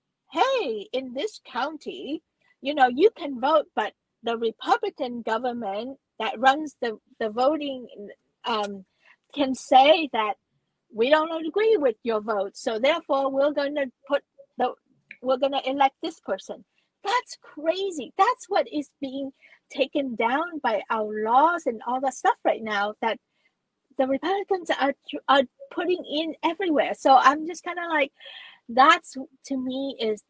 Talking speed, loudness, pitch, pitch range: 150 wpm, -25 LUFS, 270 Hz, 250-315 Hz